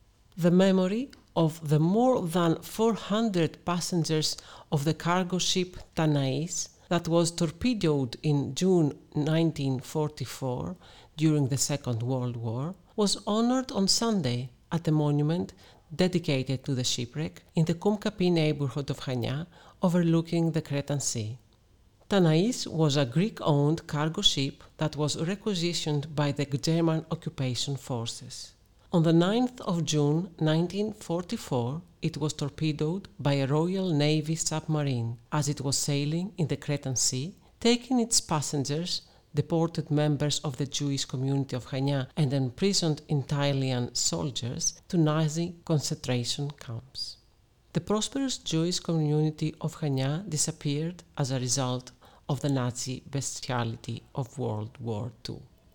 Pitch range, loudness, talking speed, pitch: 135-170 Hz, -28 LUFS, 130 wpm, 150 Hz